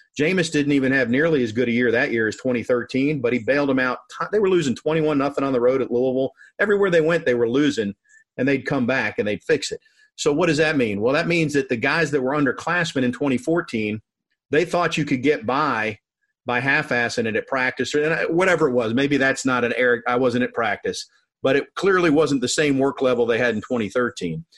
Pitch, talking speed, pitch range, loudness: 135 Hz, 230 wpm, 125-160 Hz, -21 LUFS